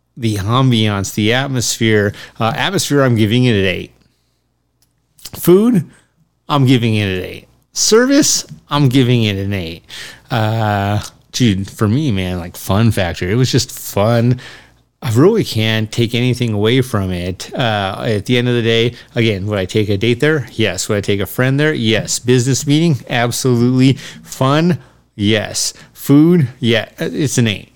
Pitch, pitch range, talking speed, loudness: 115 Hz, 105-130 Hz, 160 wpm, -15 LUFS